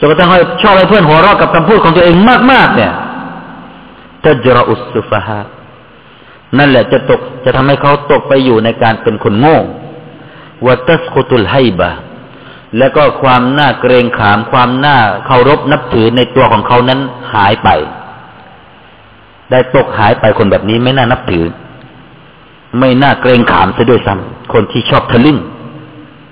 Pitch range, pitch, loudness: 120-155 Hz, 130 Hz, -8 LUFS